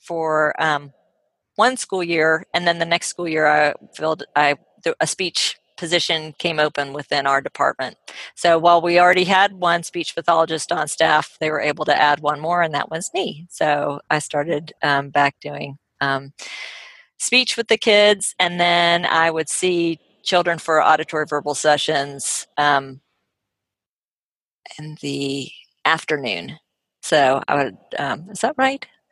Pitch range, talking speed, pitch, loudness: 145-175 Hz, 155 wpm, 160 Hz, -19 LUFS